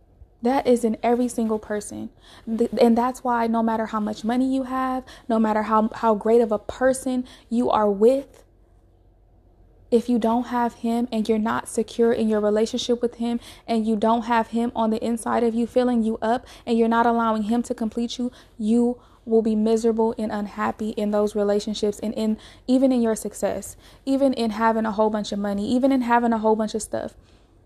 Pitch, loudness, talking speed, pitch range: 230 Hz, -23 LUFS, 200 wpm, 220-240 Hz